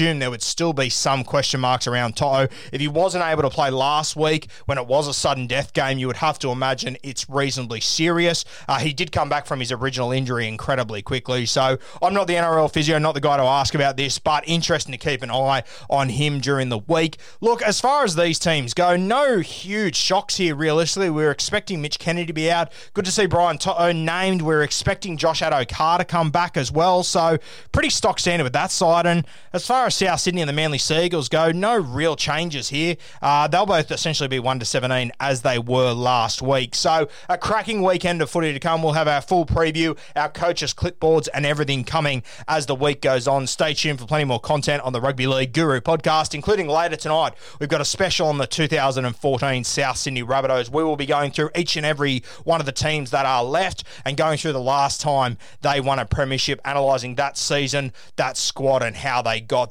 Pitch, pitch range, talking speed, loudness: 150 Hz, 135-165 Hz, 220 wpm, -21 LUFS